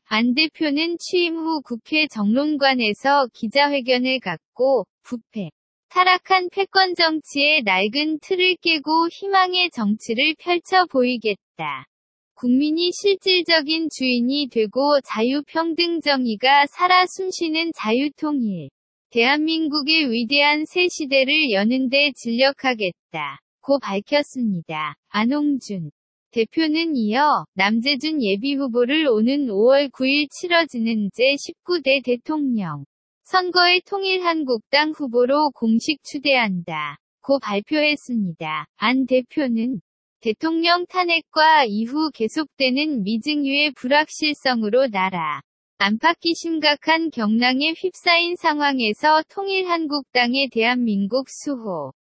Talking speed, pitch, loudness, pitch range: 245 characters per minute, 280 Hz, -19 LUFS, 235-320 Hz